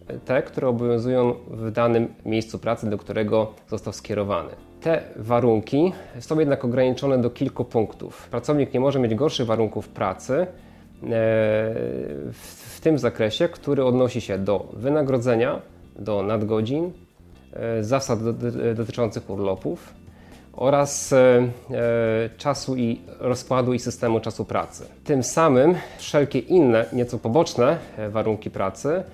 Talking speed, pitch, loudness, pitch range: 115 wpm, 120 Hz, -23 LUFS, 110-130 Hz